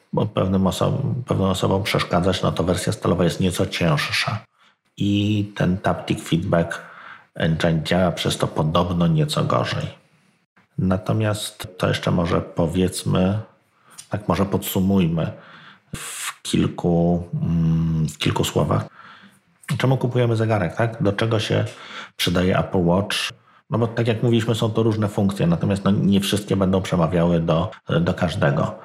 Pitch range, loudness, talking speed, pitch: 85-115 Hz, -21 LUFS, 130 wpm, 100 Hz